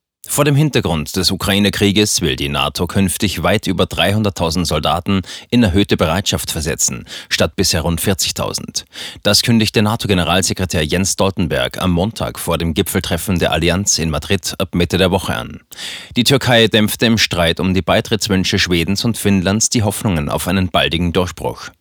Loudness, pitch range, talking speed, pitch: -15 LUFS, 85-105 Hz, 155 wpm, 95 Hz